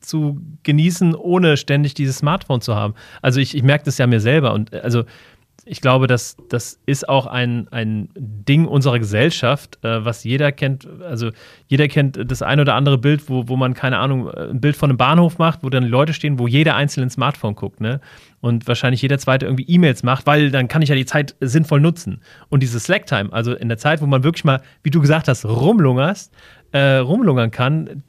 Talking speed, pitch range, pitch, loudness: 210 wpm, 125-150 Hz, 135 Hz, -17 LUFS